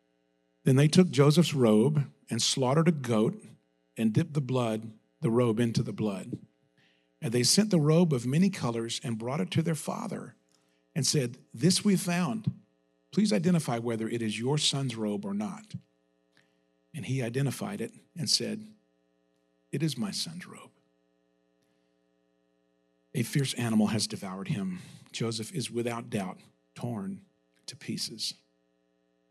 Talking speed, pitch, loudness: 145 wpm, 115 Hz, -29 LUFS